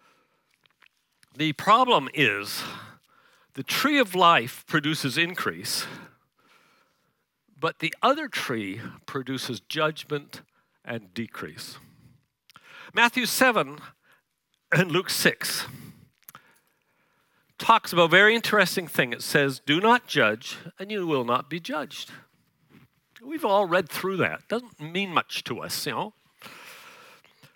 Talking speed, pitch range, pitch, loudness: 115 wpm, 140-230 Hz, 170 Hz, -24 LUFS